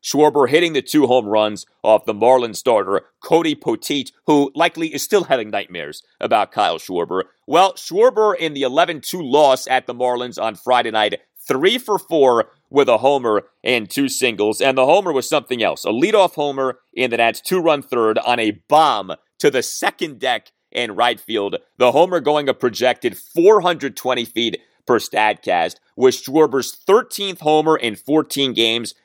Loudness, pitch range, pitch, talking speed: -17 LUFS, 125-170 Hz, 135 Hz, 170 wpm